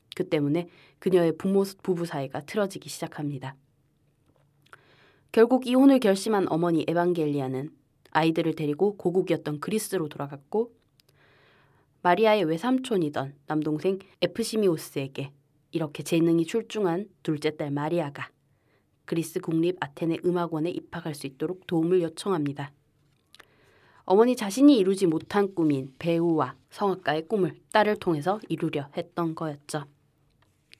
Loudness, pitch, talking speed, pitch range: -26 LUFS, 165 Hz, 310 characters per minute, 145-190 Hz